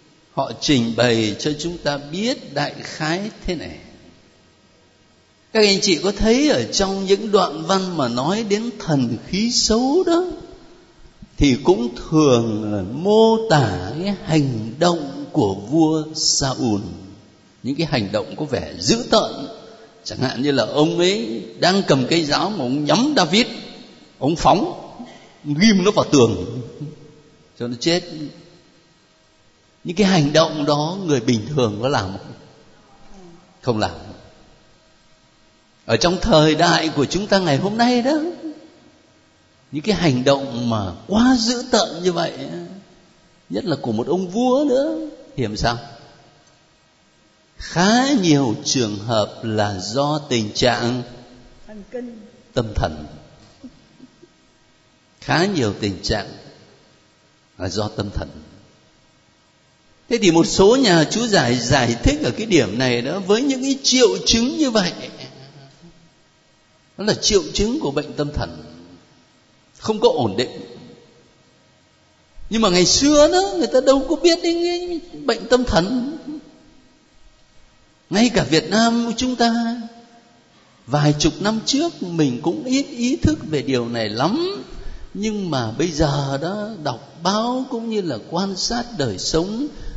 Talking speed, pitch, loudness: 140 wpm, 165 Hz, -19 LUFS